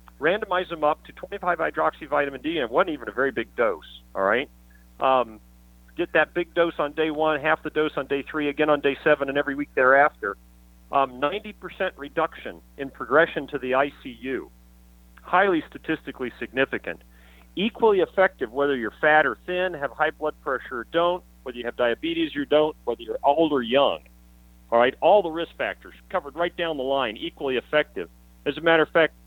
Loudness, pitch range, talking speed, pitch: -24 LUFS, 115-165 Hz, 190 wpm, 145 Hz